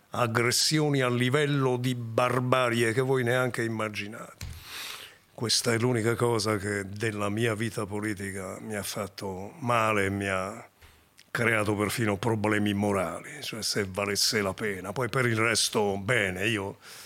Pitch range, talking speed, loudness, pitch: 100-120 Hz, 140 wpm, -27 LUFS, 110 Hz